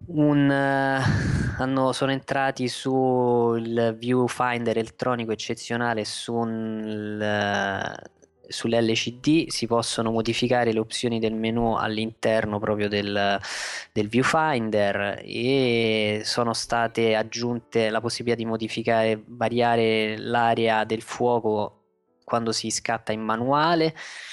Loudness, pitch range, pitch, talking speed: -24 LUFS, 110-125 Hz, 115 Hz, 95 wpm